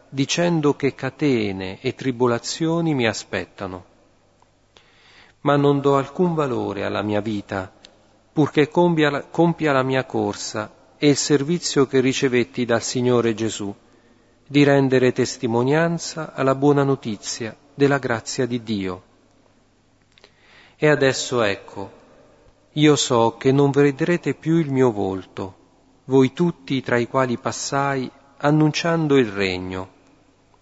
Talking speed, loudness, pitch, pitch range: 120 wpm, -20 LUFS, 130 Hz, 110-145 Hz